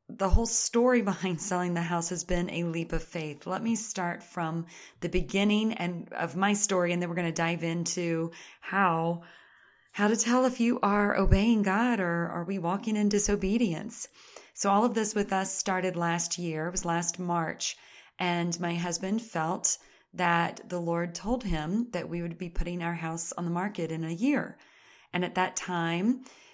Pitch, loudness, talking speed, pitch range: 180 Hz, -29 LUFS, 190 wpm, 170-205 Hz